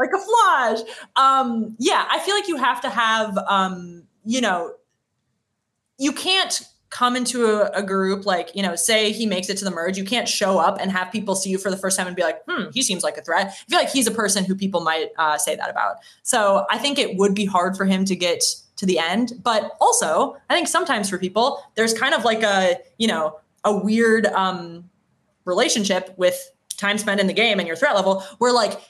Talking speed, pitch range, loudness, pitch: 230 wpm, 190-260 Hz, -20 LUFS, 210 Hz